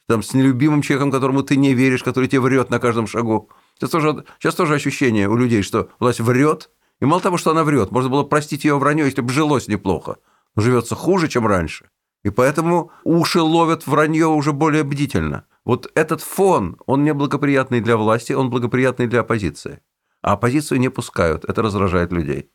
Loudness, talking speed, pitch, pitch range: -18 LUFS, 185 wpm, 135 Hz, 115-155 Hz